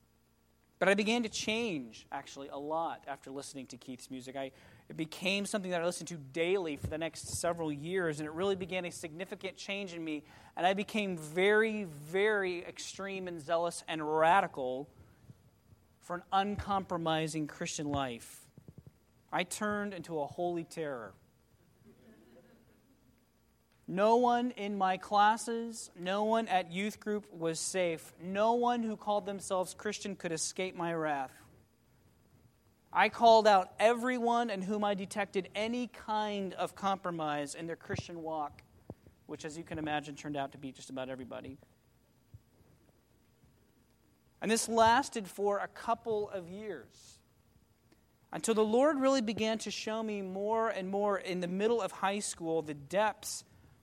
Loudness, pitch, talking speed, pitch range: -34 LUFS, 175 Hz, 150 wpm, 145-205 Hz